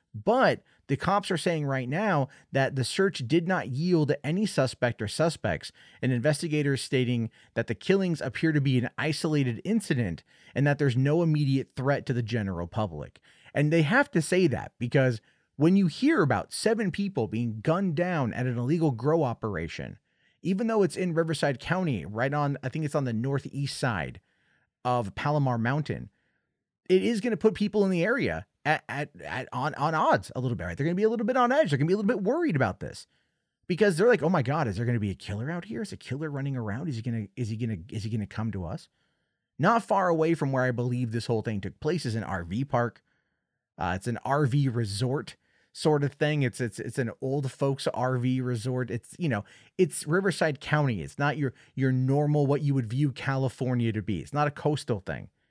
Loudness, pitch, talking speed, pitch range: -28 LUFS, 140 Hz, 225 wpm, 120-165 Hz